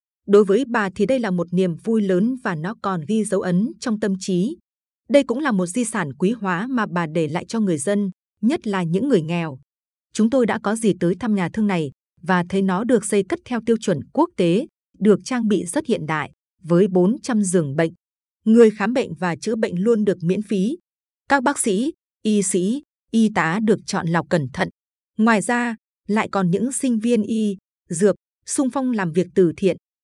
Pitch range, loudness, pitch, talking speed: 180-230 Hz, -21 LUFS, 200 Hz, 215 wpm